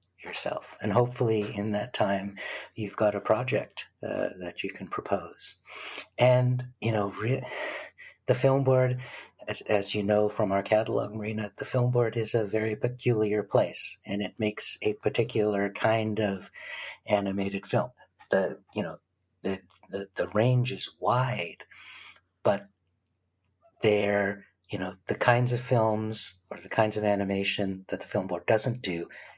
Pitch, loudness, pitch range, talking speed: 105 Hz, -29 LUFS, 100-120 Hz, 155 wpm